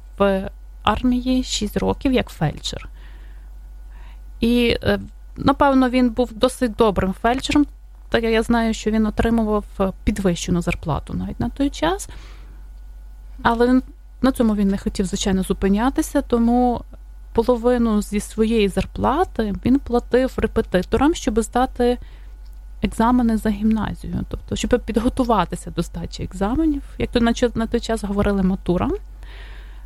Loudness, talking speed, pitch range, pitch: -20 LUFS, 120 wpm, 195-250 Hz, 225 Hz